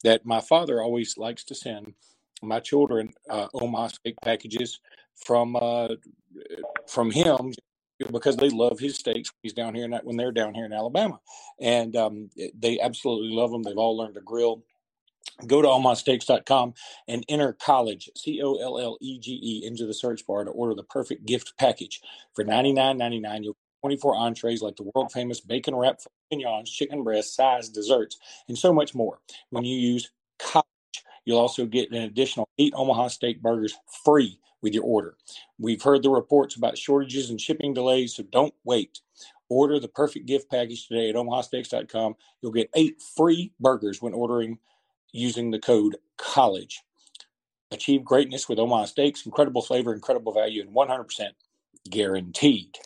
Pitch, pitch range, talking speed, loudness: 120 Hz, 115-135 Hz, 165 wpm, -25 LUFS